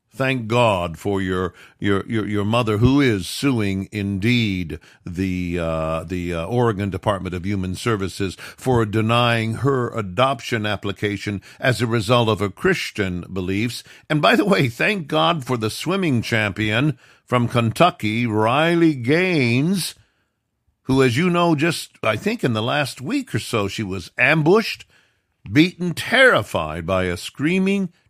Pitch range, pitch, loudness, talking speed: 100-135 Hz, 115 Hz, -20 LUFS, 145 wpm